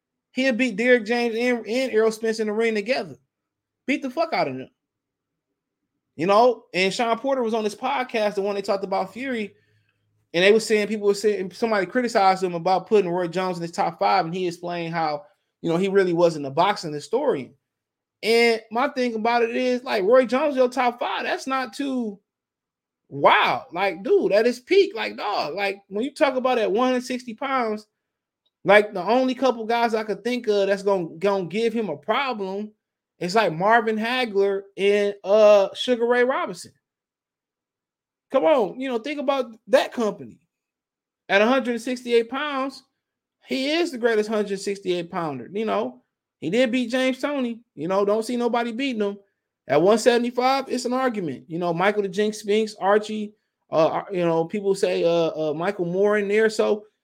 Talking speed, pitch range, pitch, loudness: 185 wpm, 195-250 Hz, 220 Hz, -22 LUFS